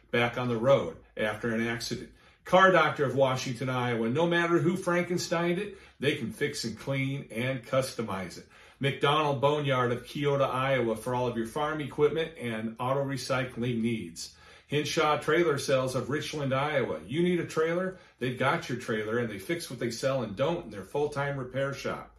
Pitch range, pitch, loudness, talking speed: 120-150 Hz, 135 Hz, -29 LUFS, 180 wpm